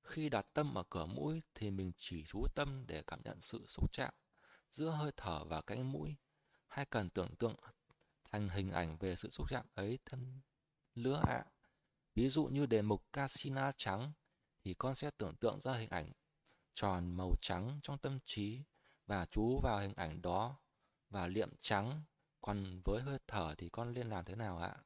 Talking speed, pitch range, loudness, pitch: 190 wpm, 95-140 Hz, -41 LUFS, 115 Hz